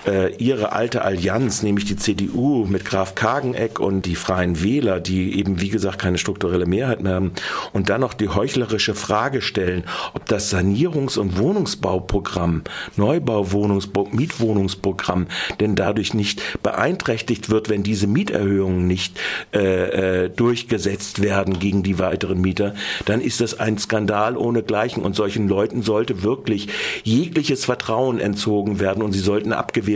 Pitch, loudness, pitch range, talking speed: 100 Hz, -21 LUFS, 95-110 Hz, 145 wpm